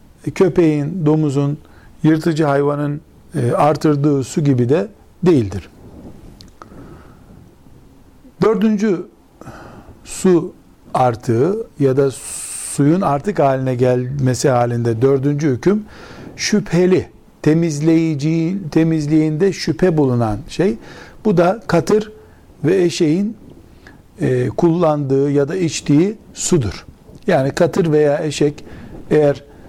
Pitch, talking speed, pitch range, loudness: 150 Hz, 85 wpm, 140-175 Hz, -16 LUFS